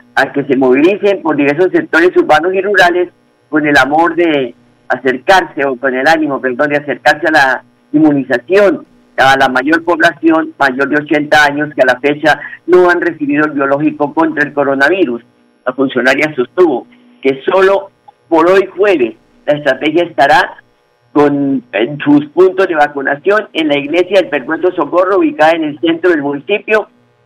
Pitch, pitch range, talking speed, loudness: 150 Hz, 135-175 Hz, 165 wpm, -11 LUFS